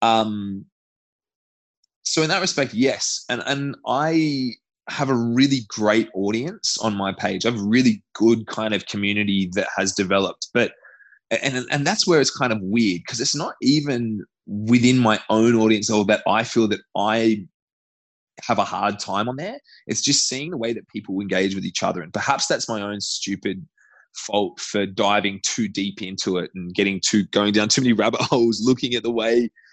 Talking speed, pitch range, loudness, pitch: 185 wpm, 100-125 Hz, -21 LUFS, 110 Hz